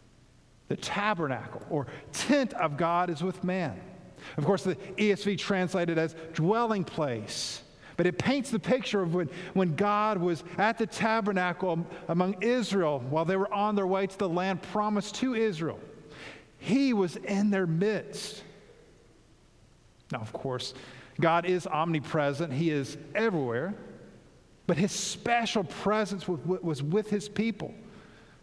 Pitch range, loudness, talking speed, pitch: 160-205 Hz, -29 LUFS, 140 wpm, 185 Hz